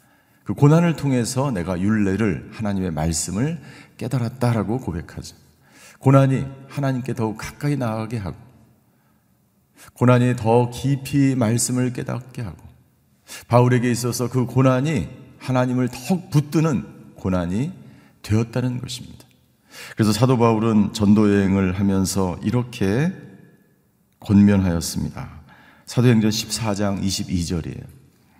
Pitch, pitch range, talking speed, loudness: 120 Hz, 100-130 Hz, 265 characters per minute, -20 LUFS